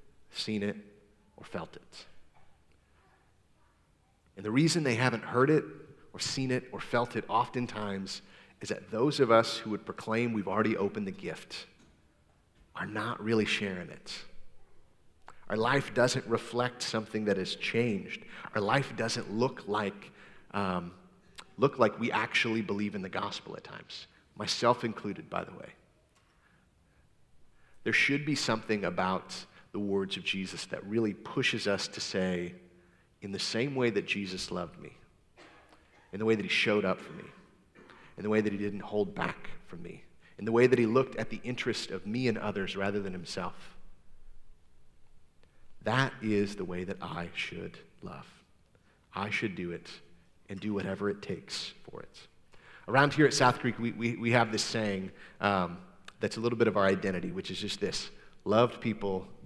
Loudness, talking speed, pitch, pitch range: -31 LUFS, 170 wpm, 105 Hz, 95-115 Hz